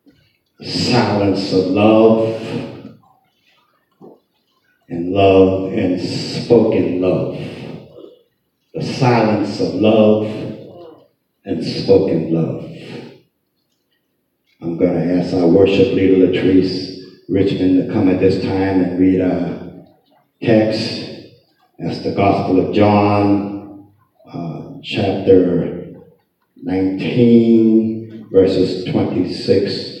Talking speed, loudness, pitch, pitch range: 85 wpm, -15 LUFS, 95 Hz, 95-110 Hz